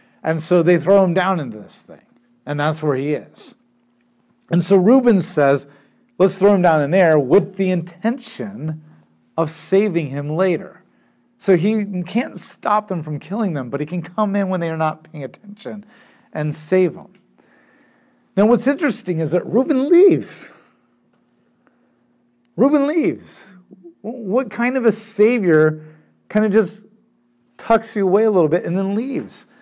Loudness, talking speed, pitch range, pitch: -18 LUFS, 160 wpm, 155-215 Hz, 185 Hz